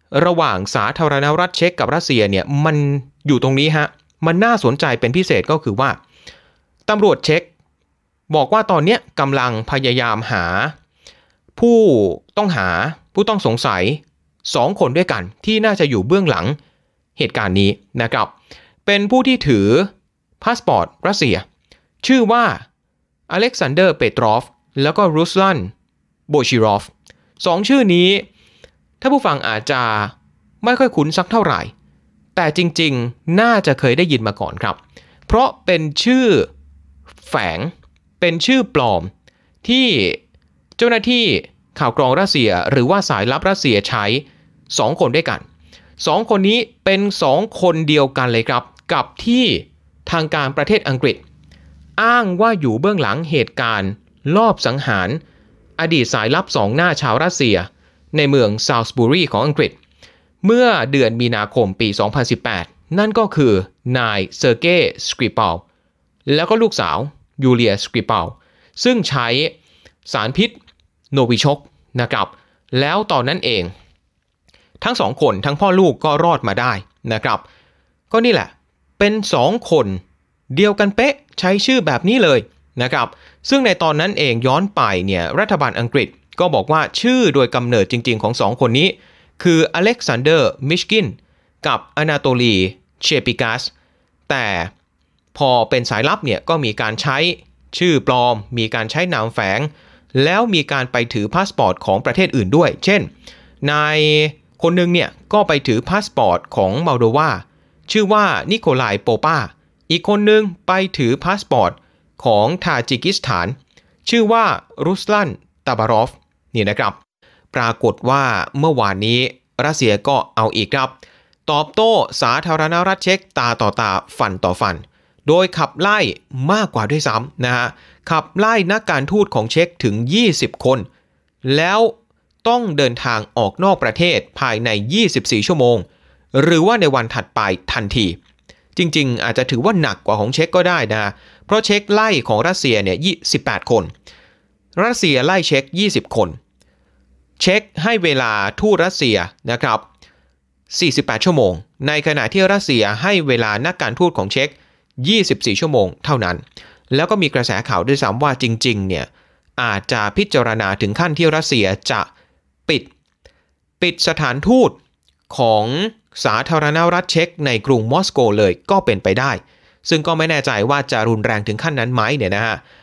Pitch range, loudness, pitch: 115-185 Hz, -16 LUFS, 145 Hz